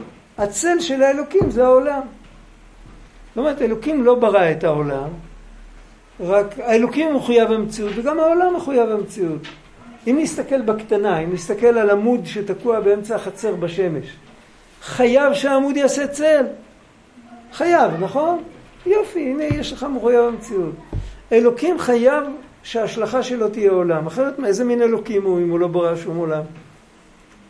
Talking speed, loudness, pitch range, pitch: 135 wpm, -18 LUFS, 200-275 Hz, 235 Hz